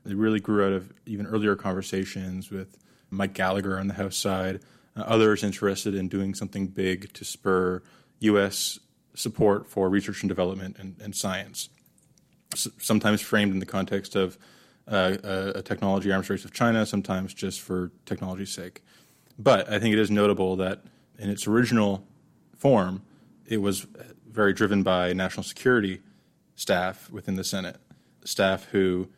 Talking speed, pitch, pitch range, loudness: 155 wpm, 100 Hz, 95-105 Hz, -26 LUFS